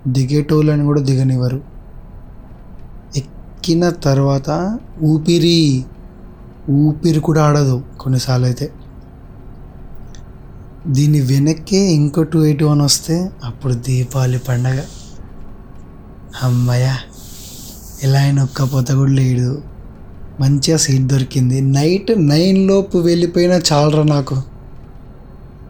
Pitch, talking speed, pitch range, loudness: 140 Hz, 80 wpm, 130-155 Hz, -15 LUFS